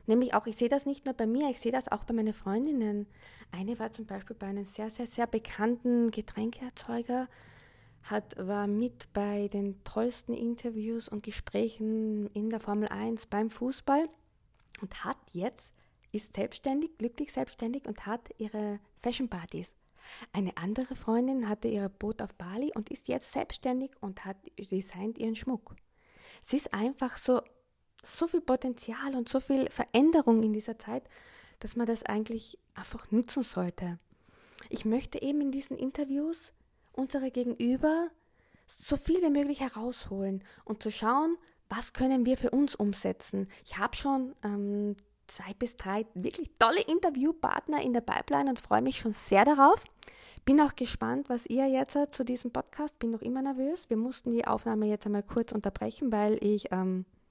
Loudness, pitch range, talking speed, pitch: -32 LUFS, 210-265 Hz, 165 wpm, 235 Hz